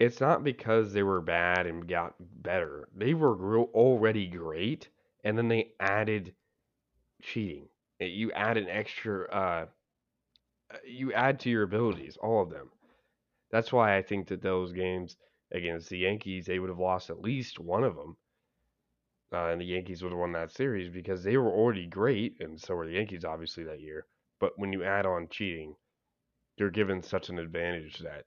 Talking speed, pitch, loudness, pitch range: 180 wpm, 95 Hz, -31 LUFS, 85-110 Hz